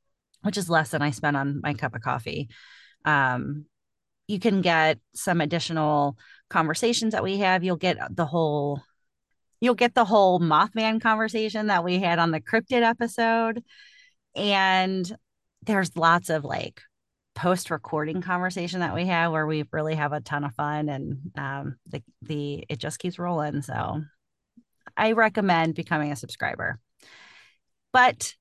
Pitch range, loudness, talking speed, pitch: 150-205 Hz, -25 LUFS, 150 wpm, 170 Hz